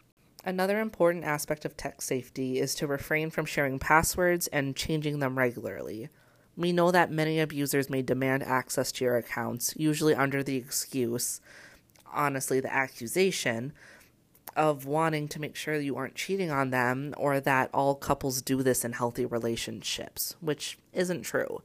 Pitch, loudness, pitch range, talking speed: 140 Hz, -29 LUFS, 130-155 Hz, 155 wpm